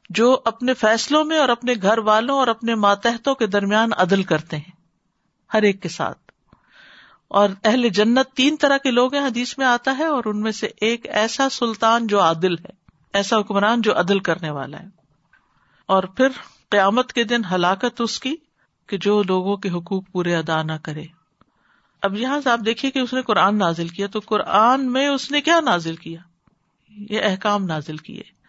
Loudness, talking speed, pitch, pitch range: -19 LUFS, 185 wpm, 215 Hz, 190-245 Hz